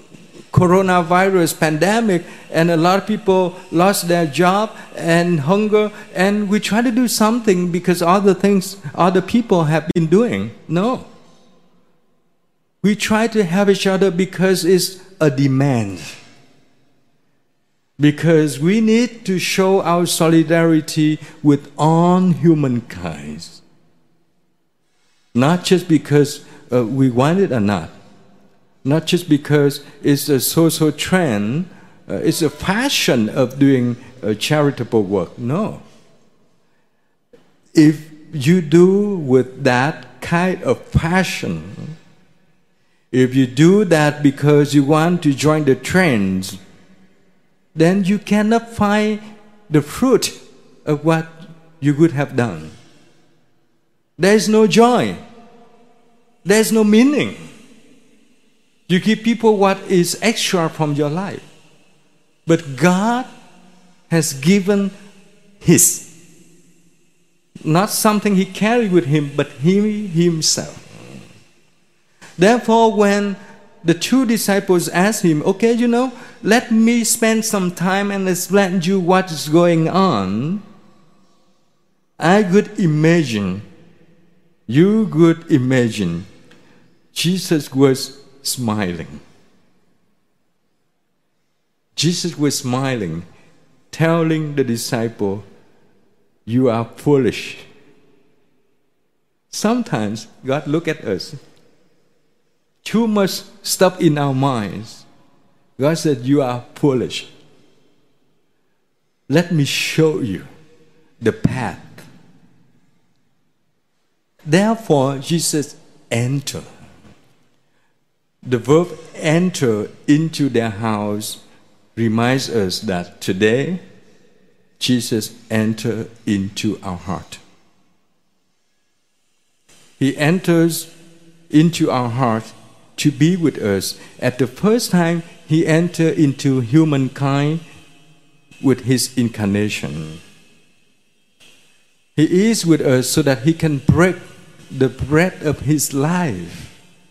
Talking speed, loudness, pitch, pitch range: 100 wpm, -16 LUFS, 165 Hz, 140-190 Hz